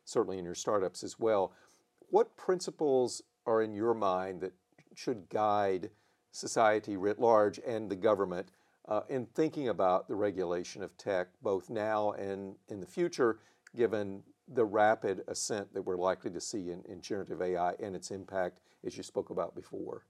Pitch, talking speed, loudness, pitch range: 105 Hz, 165 wpm, -33 LUFS, 95-115 Hz